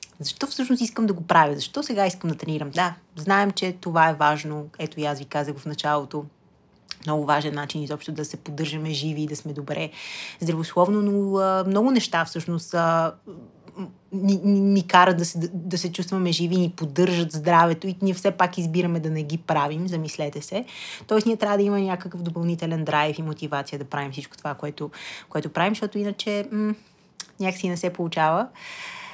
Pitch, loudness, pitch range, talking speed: 170 Hz, -24 LUFS, 155-195 Hz, 185 wpm